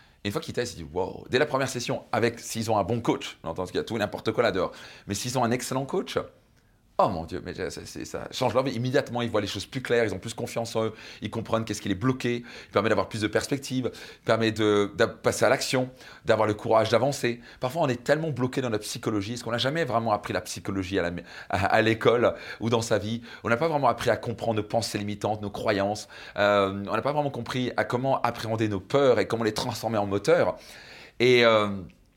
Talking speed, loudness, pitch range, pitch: 245 wpm, -27 LUFS, 105-125 Hz, 115 Hz